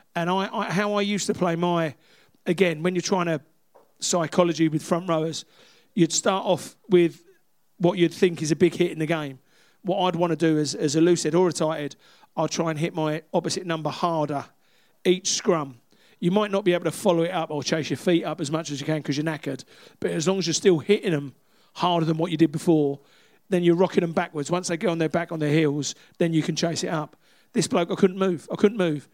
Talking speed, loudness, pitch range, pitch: 245 wpm, -24 LUFS, 155-180 Hz, 170 Hz